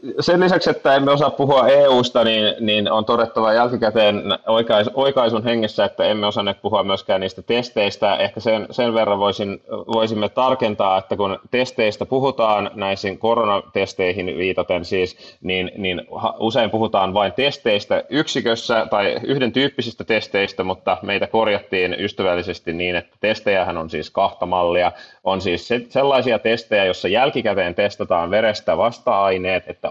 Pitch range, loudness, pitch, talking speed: 95-120 Hz, -19 LUFS, 110 Hz, 140 wpm